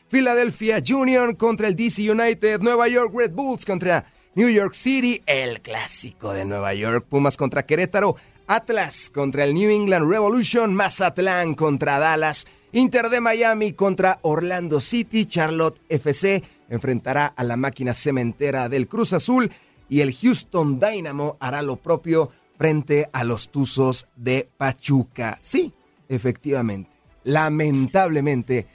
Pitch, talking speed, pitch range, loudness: 155 Hz, 130 wpm, 135-215 Hz, -20 LUFS